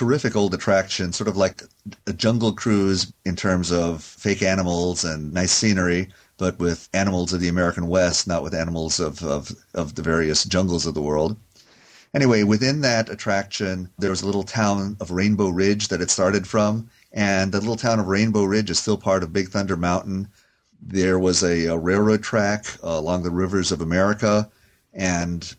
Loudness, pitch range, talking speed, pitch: -22 LUFS, 90-105 Hz, 185 wpm, 95 Hz